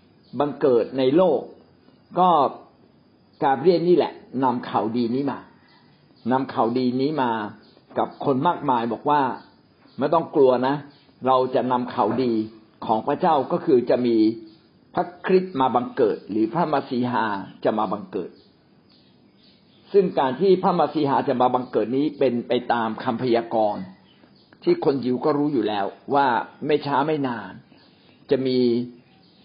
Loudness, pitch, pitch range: -22 LUFS, 130 Hz, 120-150 Hz